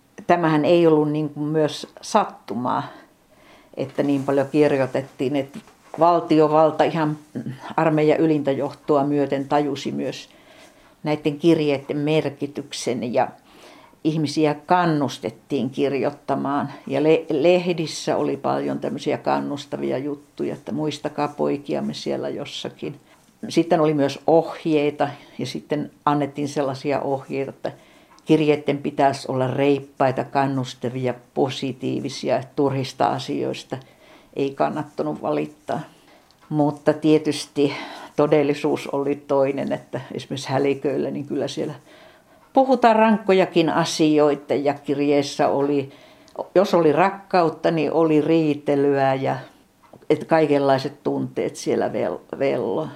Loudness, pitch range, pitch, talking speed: -22 LUFS, 140-155 Hz, 145 Hz, 100 wpm